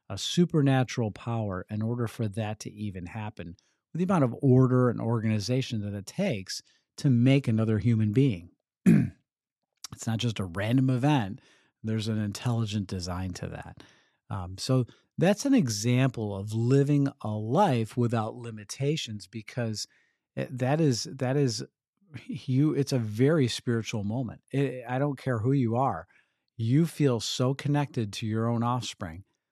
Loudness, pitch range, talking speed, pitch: -28 LUFS, 110-135 Hz, 150 wpm, 120 Hz